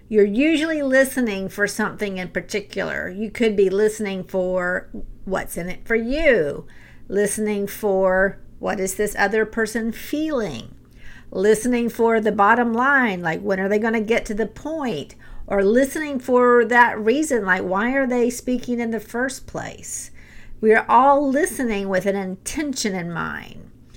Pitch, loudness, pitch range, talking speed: 220 Hz, -20 LUFS, 200-245 Hz, 160 wpm